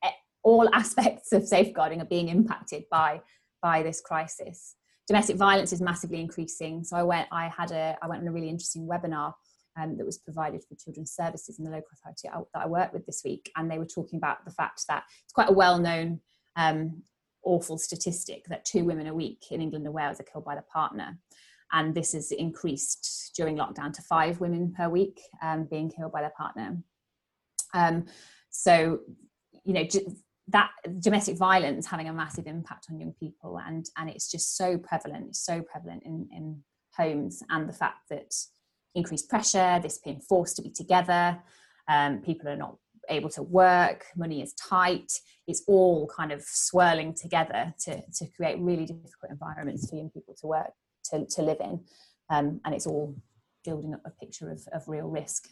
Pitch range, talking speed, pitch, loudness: 155-180 Hz, 190 wpm, 165 Hz, -28 LUFS